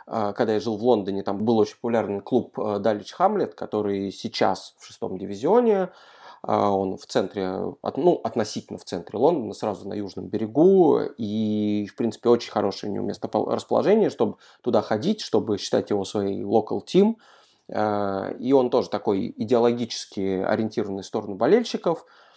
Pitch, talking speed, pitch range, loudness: 105 Hz, 150 wpm, 100-120 Hz, -24 LUFS